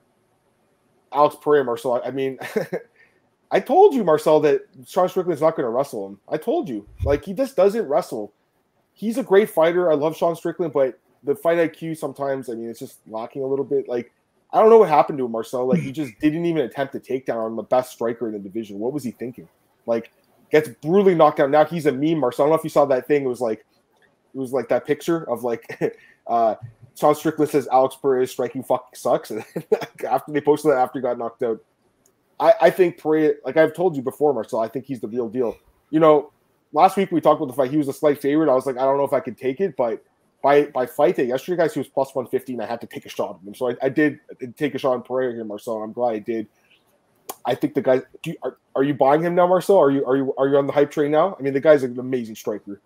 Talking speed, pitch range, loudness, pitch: 260 wpm, 125-160 Hz, -21 LUFS, 140 Hz